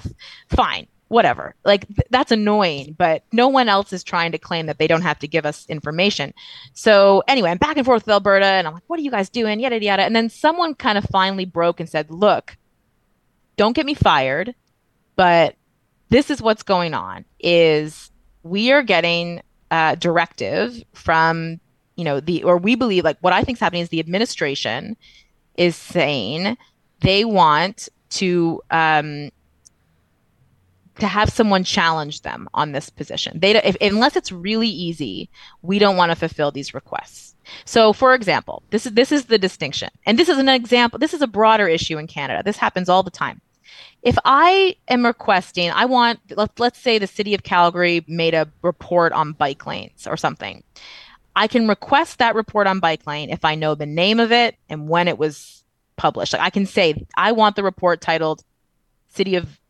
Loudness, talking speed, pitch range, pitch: -18 LUFS, 190 wpm, 160-220 Hz, 185 Hz